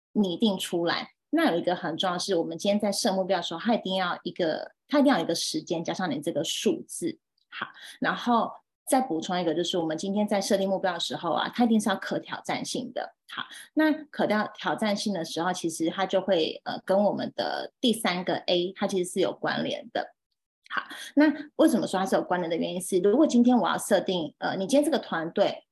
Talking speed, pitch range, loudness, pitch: 325 characters per minute, 180-235 Hz, -27 LUFS, 195 Hz